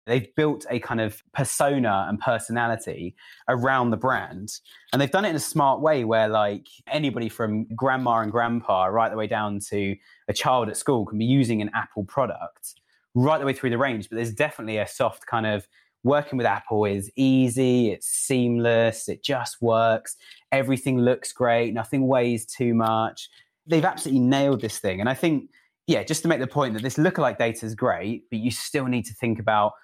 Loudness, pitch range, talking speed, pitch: -24 LUFS, 110-135 Hz, 195 wpm, 120 Hz